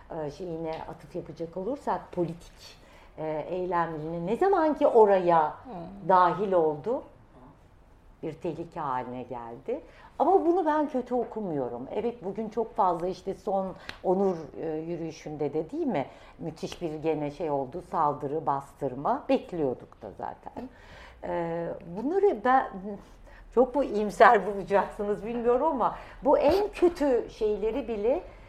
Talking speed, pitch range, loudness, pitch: 120 wpm, 160-235 Hz, -28 LUFS, 180 Hz